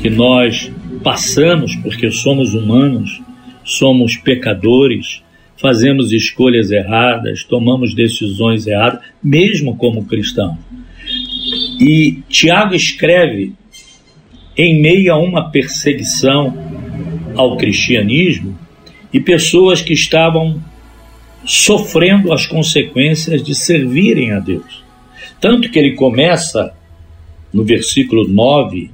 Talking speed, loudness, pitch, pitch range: 95 wpm, -12 LUFS, 135 Hz, 115-160 Hz